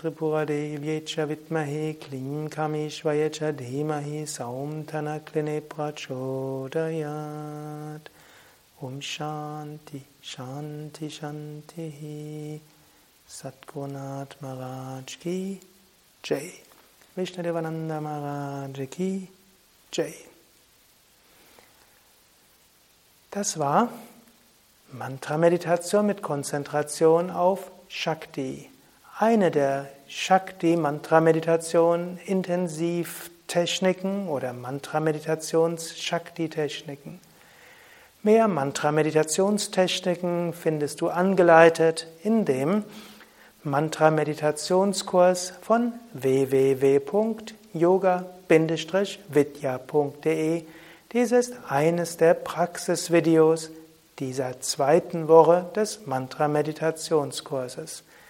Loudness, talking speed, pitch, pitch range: -25 LUFS, 65 wpm, 160 Hz, 150-175 Hz